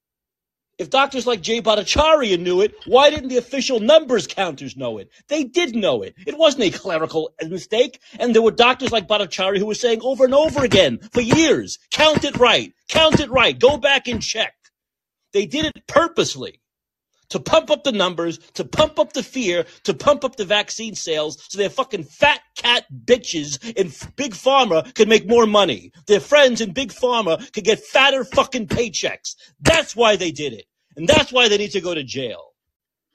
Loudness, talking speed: -18 LUFS, 190 wpm